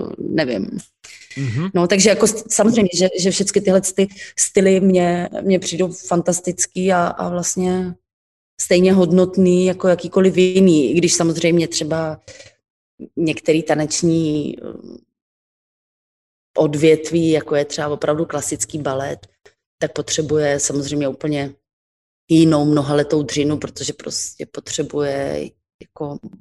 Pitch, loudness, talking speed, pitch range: 165 Hz, -17 LUFS, 105 wpm, 150-185 Hz